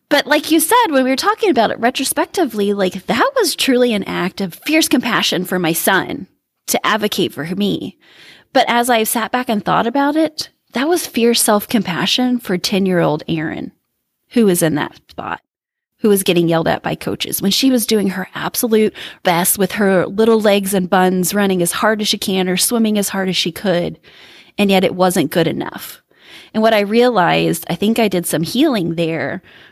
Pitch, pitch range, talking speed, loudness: 210 Hz, 185-250 Hz, 200 wpm, -15 LUFS